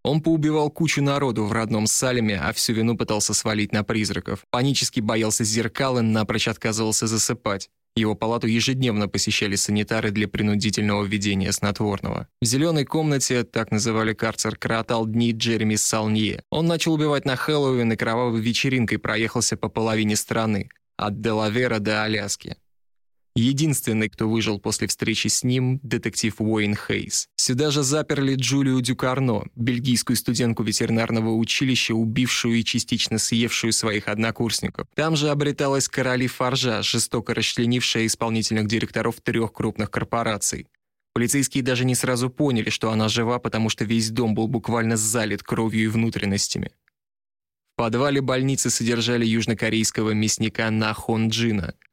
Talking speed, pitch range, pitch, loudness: 140 wpm, 110-125 Hz, 115 Hz, -22 LUFS